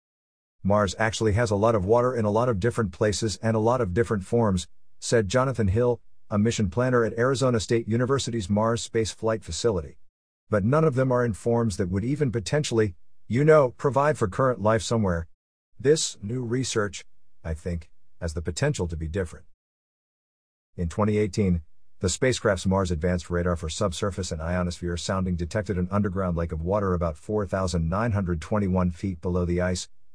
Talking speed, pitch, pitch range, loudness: 170 wpm, 105 Hz, 90-115 Hz, -25 LUFS